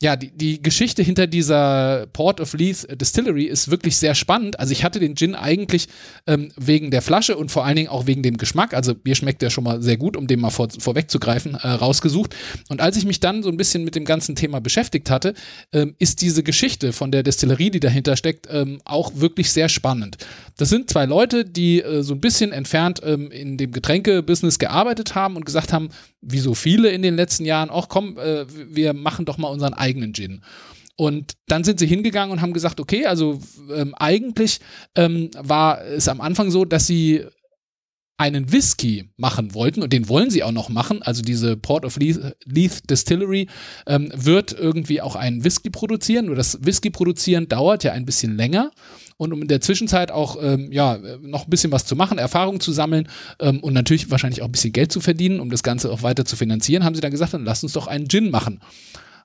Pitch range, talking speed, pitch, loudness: 135-175 Hz, 215 wpm, 155 Hz, -19 LUFS